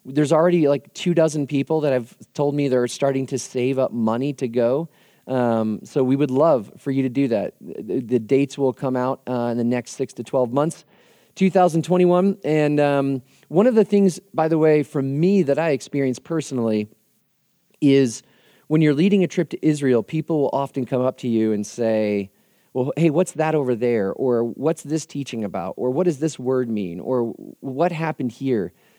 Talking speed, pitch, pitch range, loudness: 200 wpm, 140 Hz, 125-160 Hz, -21 LUFS